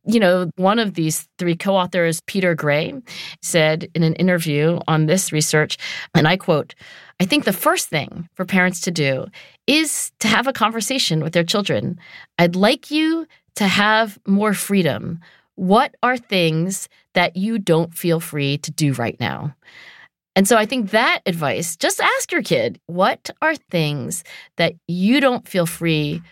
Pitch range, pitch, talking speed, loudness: 165-215 Hz, 180 Hz, 165 wpm, -19 LUFS